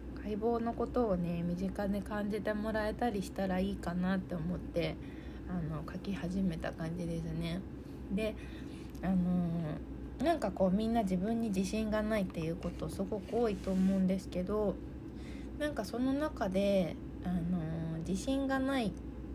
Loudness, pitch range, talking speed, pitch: -35 LUFS, 175-220 Hz, 300 characters per minute, 190 Hz